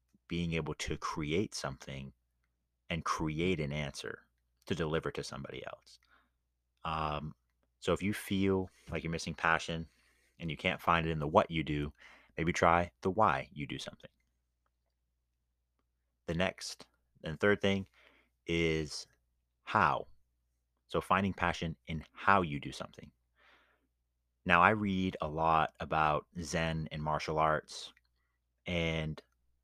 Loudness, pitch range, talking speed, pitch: -34 LUFS, 60-85 Hz, 135 wpm, 75 Hz